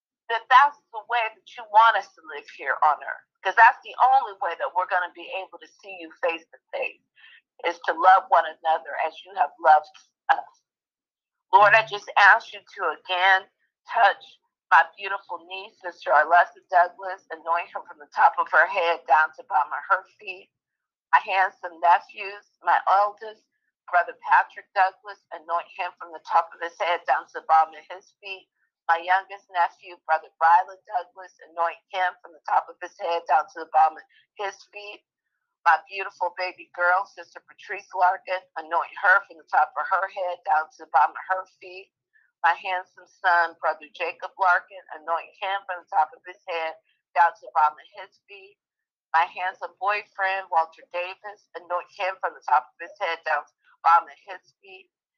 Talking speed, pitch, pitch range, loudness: 190 wpm, 180 Hz, 170-200 Hz, -23 LUFS